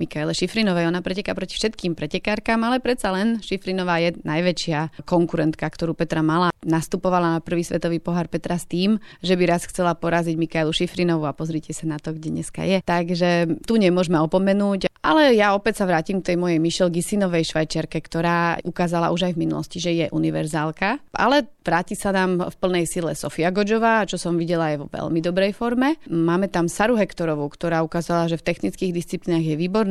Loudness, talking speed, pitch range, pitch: -22 LUFS, 185 wpm, 165-190 Hz, 175 Hz